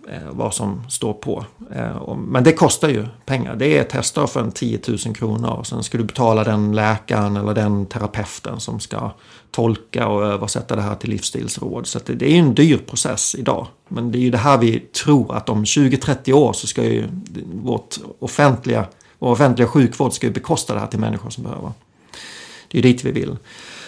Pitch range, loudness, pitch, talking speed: 110-135 Hz, -19 LUFS, 120 Hz, 200 wpm